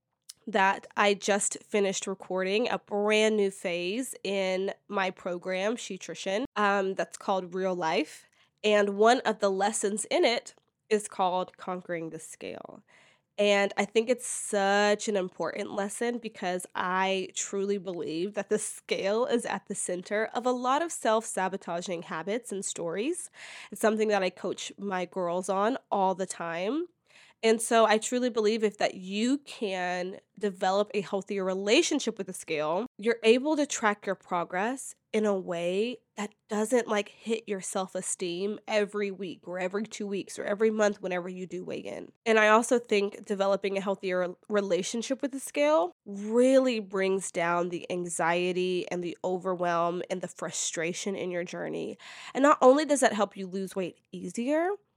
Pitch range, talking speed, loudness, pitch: 185-220 Hz, 165 wpm, -29 LUFS, 200 Hz